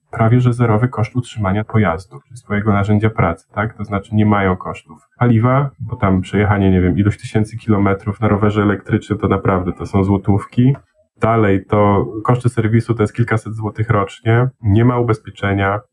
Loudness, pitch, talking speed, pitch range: -16 LUFS, 105 Hz, 170 wpm, 100-120 Hz